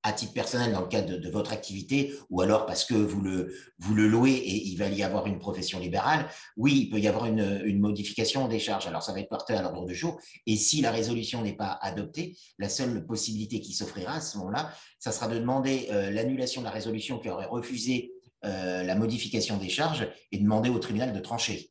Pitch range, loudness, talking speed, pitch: 100-120 Hz, -29 LUFS, 230 wpm, 110 Hz